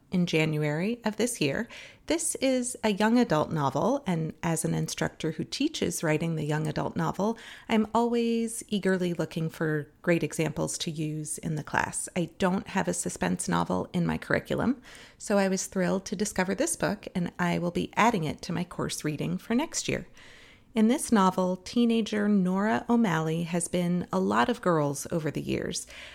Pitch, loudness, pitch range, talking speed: 180 Hz, -28 LUFS, 160-220 Hz, 180 wpm